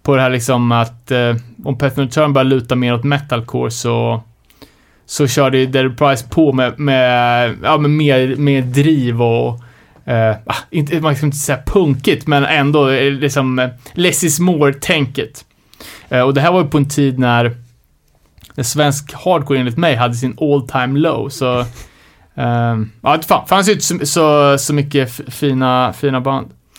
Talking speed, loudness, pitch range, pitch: 170 wpm, -14 LUFS, 125-145 Hz, 135 Hz